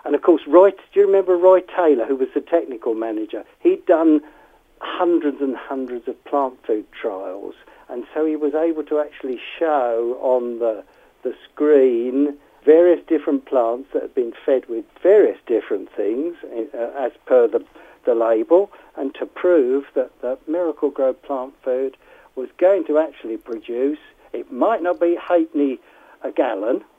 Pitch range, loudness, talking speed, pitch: 135-195 Hz, -19 LUFS, 165 wpm, 155 Hz